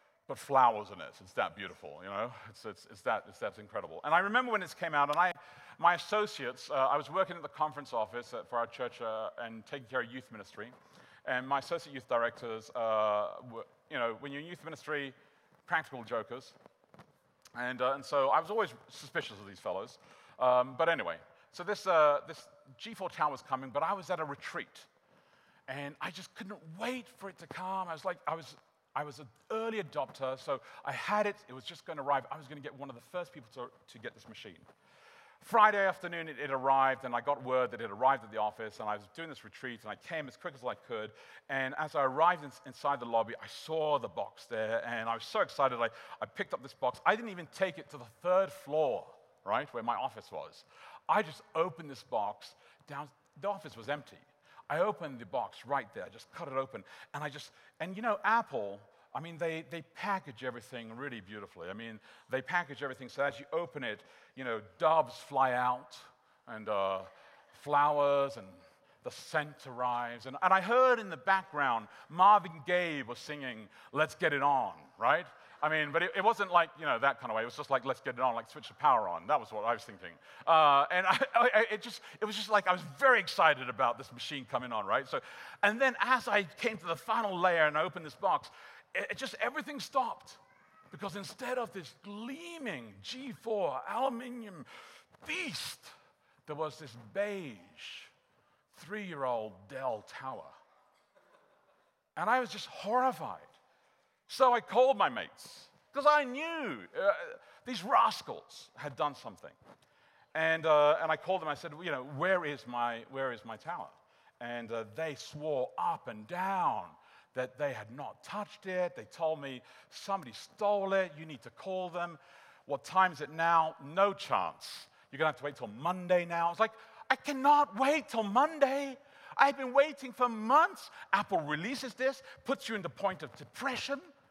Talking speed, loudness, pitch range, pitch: 205 wpm, -33 LUFS, 130-205 Hz, 160 Hz